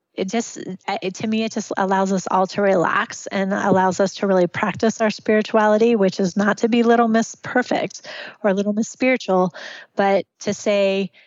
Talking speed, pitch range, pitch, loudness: 180 wpm, 195-225 Hz, 205 Hz, -20 LUFS